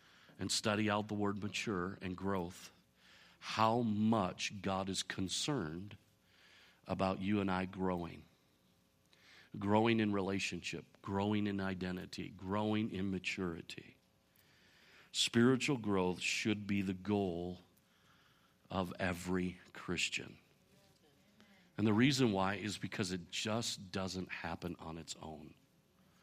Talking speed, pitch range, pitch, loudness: 110 wpm, 90-105 Hz, 95 Hz, -37 LUFS